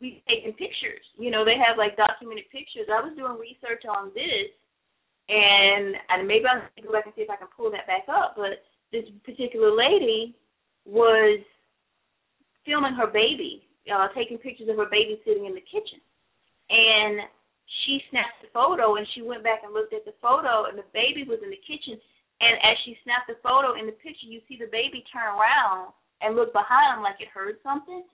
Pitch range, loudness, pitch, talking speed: 215-275 Hz, -23 LUFS, 230 Hz, 195 wpm